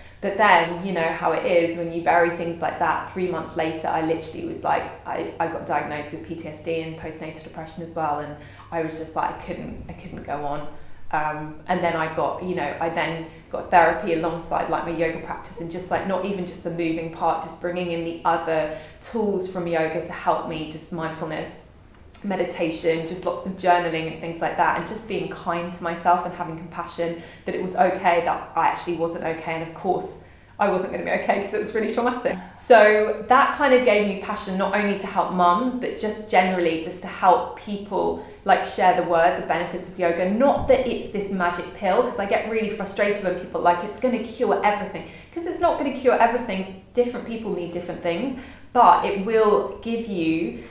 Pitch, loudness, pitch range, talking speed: 175 Hz, -23 LUFS, 165-200 Hz, 220 wpm